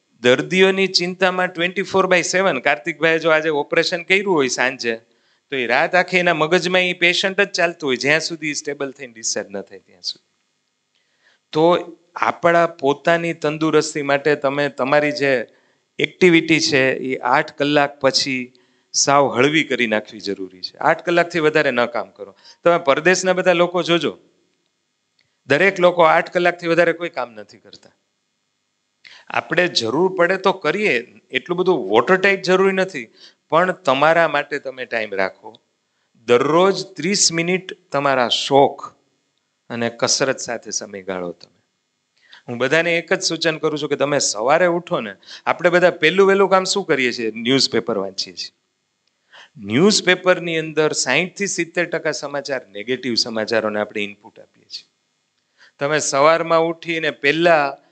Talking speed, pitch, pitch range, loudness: 140 wpm, 155 Hz, 130-175 Hz, -18 LUFS